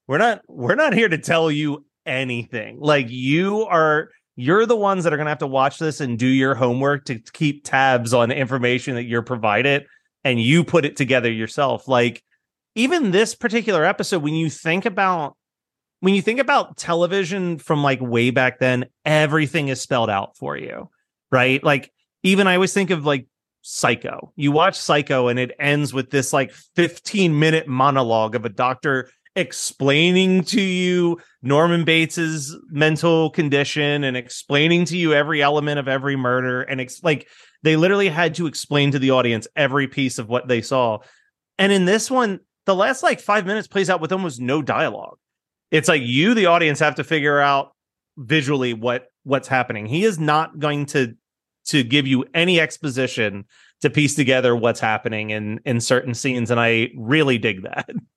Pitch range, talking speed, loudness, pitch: 130-170 Hz, 180 wpm, -19 LUFS, 145 Hz